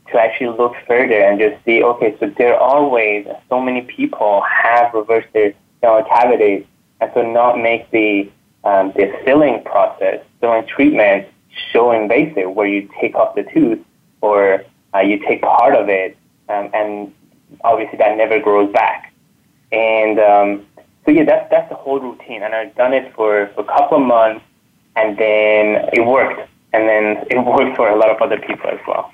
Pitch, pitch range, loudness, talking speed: 110 Hz, 105-125 Hz, -14 LUFS, 180 wpm